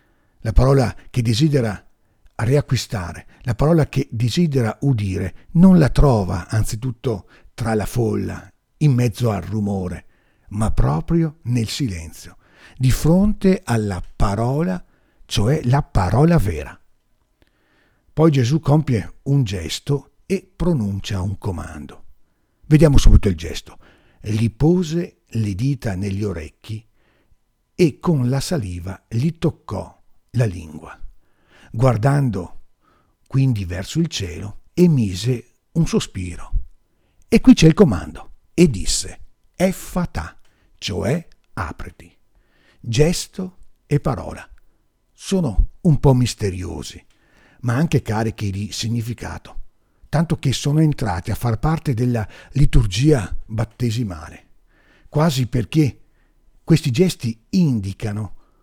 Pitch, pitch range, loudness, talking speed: 115 Hz, 95-145 Hz, -20 LUFS, 105 wpm